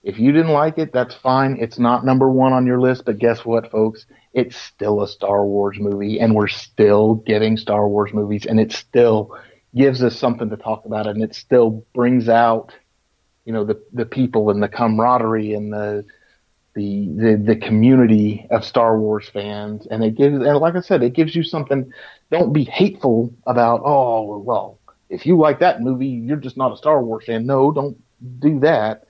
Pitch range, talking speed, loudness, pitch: 110-130 Hz, 200 wpm, -17 LUFS, 115 Hz